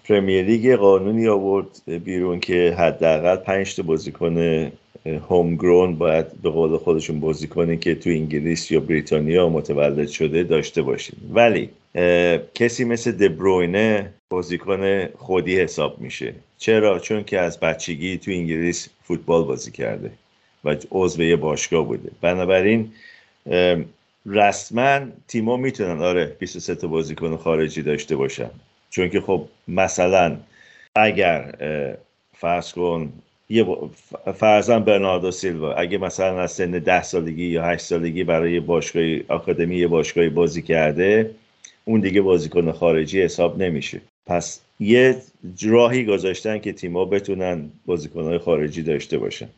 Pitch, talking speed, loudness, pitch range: 90 Hz, 125 wpm, -20 LUFS, 85-100 Hz